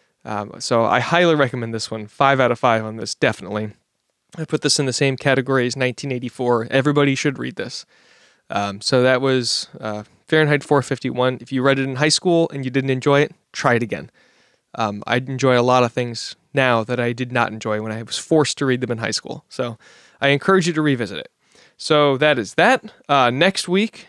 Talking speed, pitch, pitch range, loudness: 215 wpm, 130 Hz, 120-145 Hz, -19 LUFS